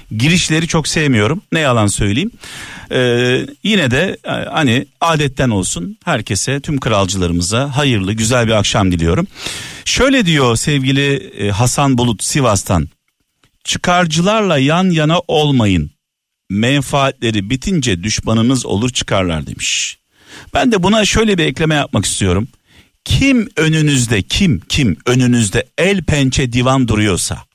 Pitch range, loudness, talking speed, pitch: 110-155 Hz, -14 LUFS, 115 wpm, 130 Hz